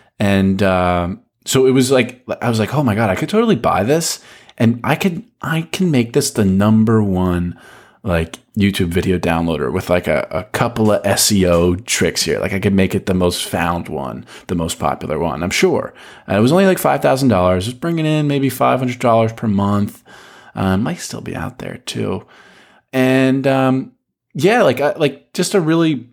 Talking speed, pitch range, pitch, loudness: 190 wpm, 95-140 Hz, 115 Hz, -16 LUFS